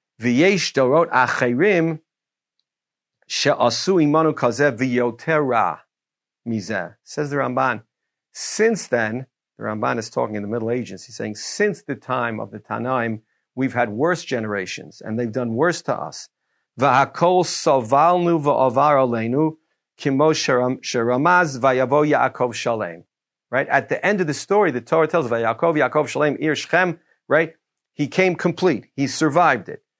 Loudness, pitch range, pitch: -20 LUFS, 120-160 Hz, 140 Hz